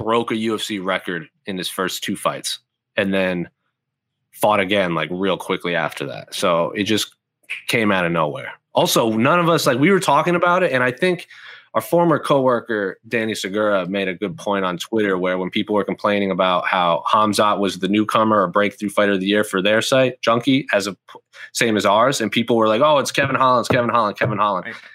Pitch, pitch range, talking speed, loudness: 105 Hz, 95-120 Hz, 210 wpm, -19 LUFS